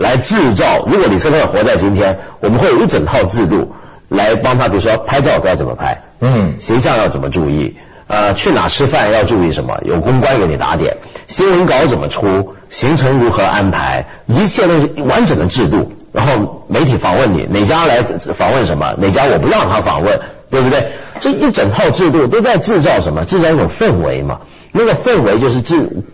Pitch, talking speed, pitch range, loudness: 100 Hz, 300 characters per minute, 95-130 Hz, -12 LUFS